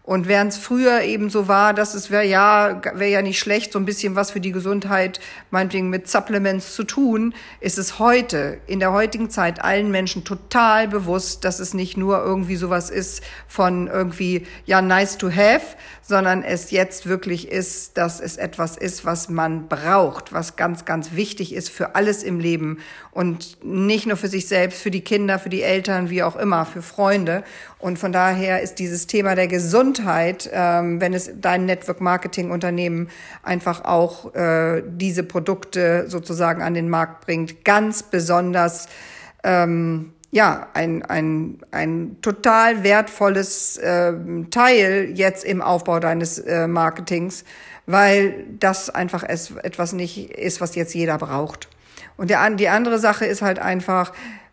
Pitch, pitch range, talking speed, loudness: 185 Hz, 175-200 Hz, 160 wpm, -20 LUFS